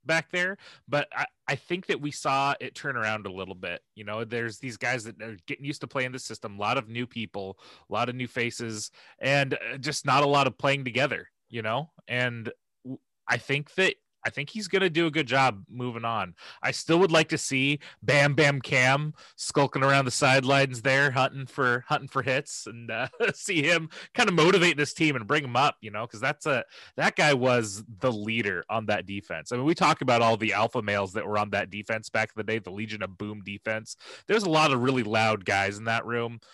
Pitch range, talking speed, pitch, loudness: 110-145 Hz, 230 wpm, 130 Hz, -26 LUFS